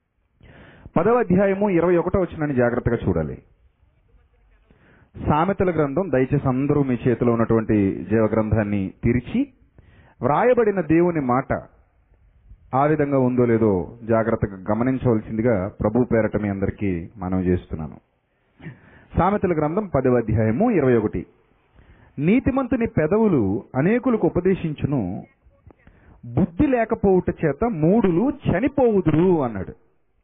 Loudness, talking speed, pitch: -21 LUFS, 95 wpm, 125 Hz